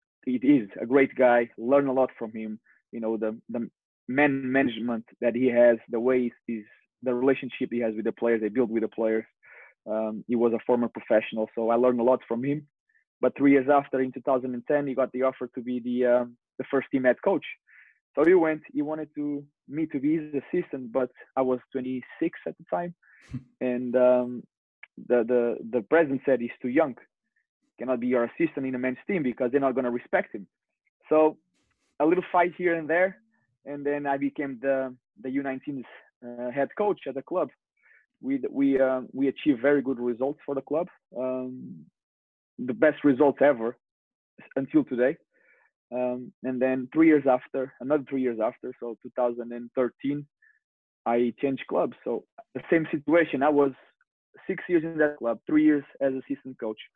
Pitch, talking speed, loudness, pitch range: 130 Hz, 190 wpm, -26 LUFS, 120-145 Hz